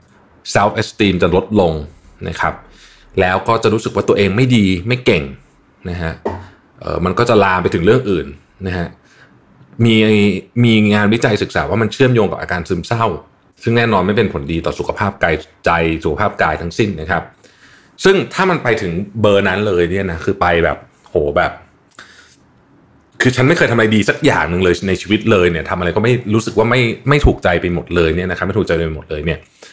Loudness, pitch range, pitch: -15 LUFS, 85-110 Hz, 100 Hz